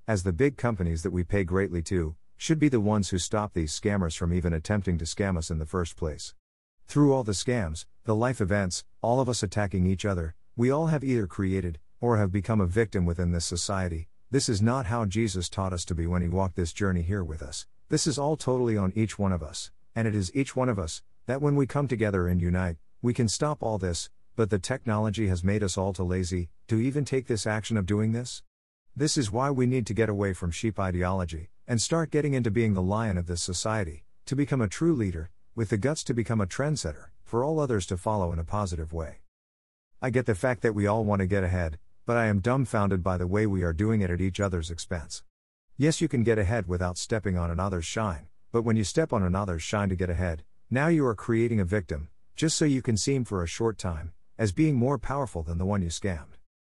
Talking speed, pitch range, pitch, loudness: 240 wpm, 90-115 Hz, 100 Hz, -28 LUFS